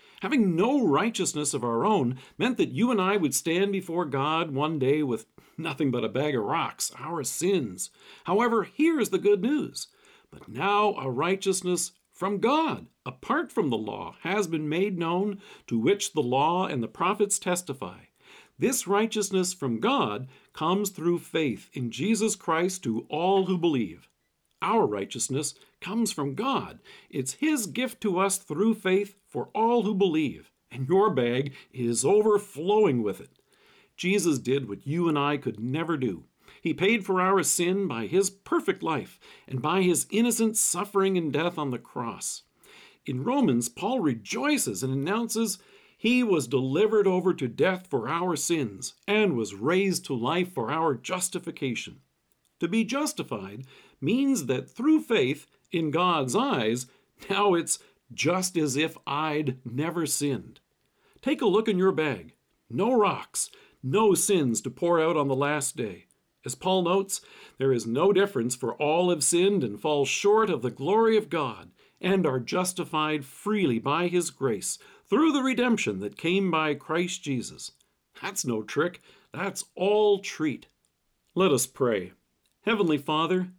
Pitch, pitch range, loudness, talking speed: 180 Hz, 140-205 Hz, -26 LUFS, 160 wpm